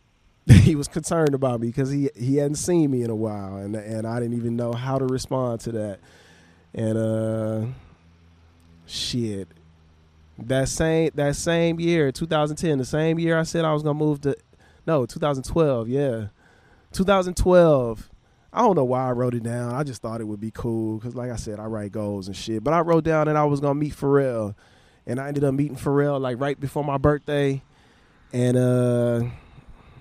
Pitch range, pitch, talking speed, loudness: 110-145 Hz, 125 Hz, 190 wpm, -23 LUFS